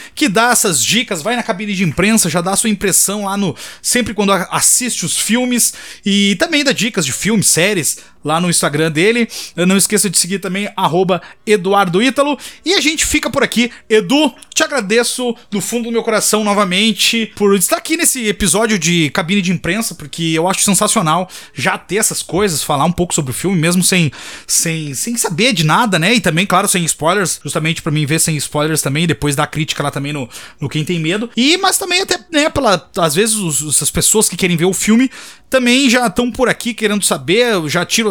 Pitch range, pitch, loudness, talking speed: 170-235 Hz, 200 Hz, -13 LUFS, 210 wpm